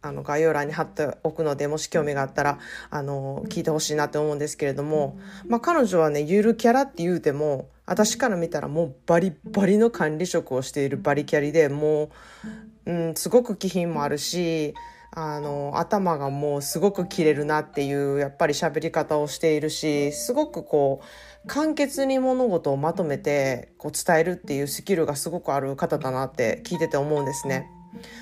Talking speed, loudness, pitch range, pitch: 375 characters per minute, -24 LUFS, 145-190 Hz, 160 Hz